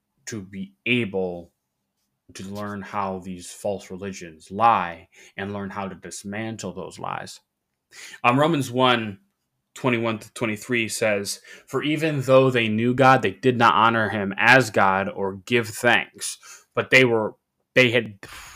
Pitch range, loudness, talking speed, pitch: 95-120 Hz, -21 LUFS, 140 wpm, 105 Hz